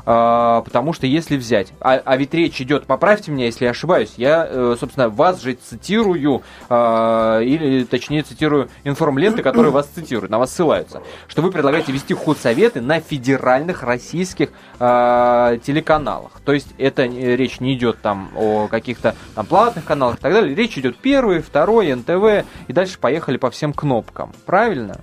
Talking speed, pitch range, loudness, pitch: 155 wpm, 120-160 Hz, -17 LUFS, 135 Hz